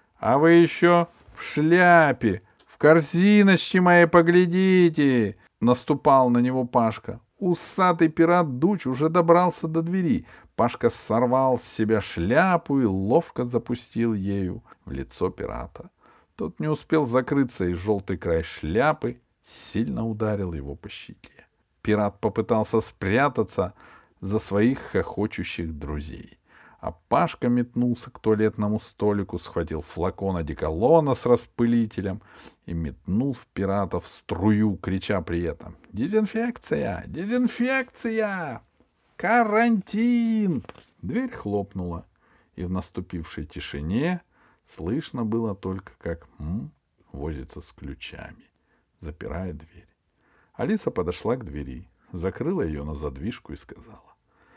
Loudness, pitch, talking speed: -23 LUFS, 115 Hz, 110 wpm